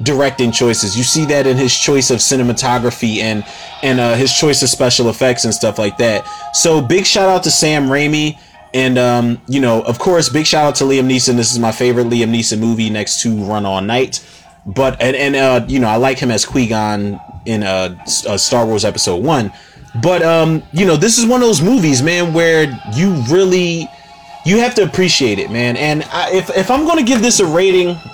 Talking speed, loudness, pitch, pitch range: 215 wpm, -13 LUFS, 135 Hz, 120-165 Hz